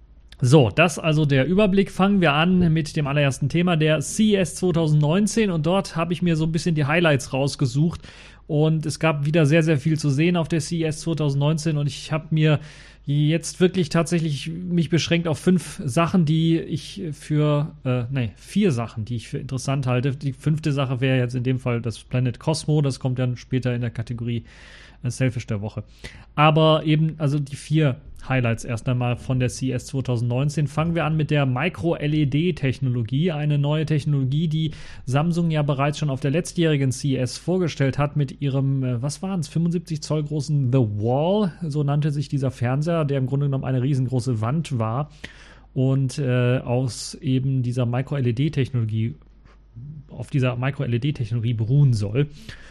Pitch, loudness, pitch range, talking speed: 145 Hz, -22 LUFS, 130-160 Hz, 170 wpm